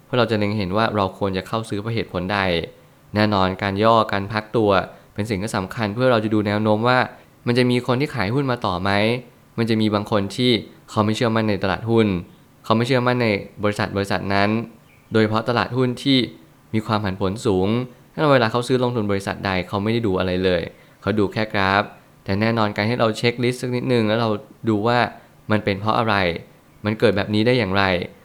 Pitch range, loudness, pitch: 100-120 Hz, -21 LUFS, 110 Hz